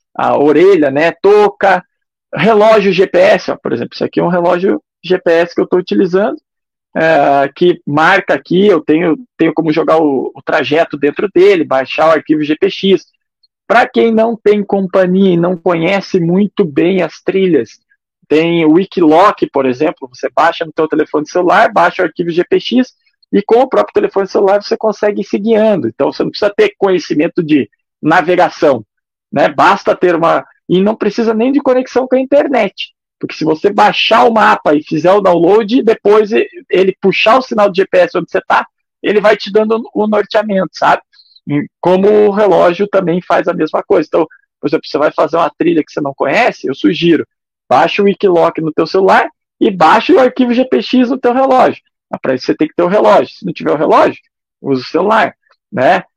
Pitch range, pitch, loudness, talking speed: 165-225 Hz, 195 Hz, -11 LUFS, 190 wpm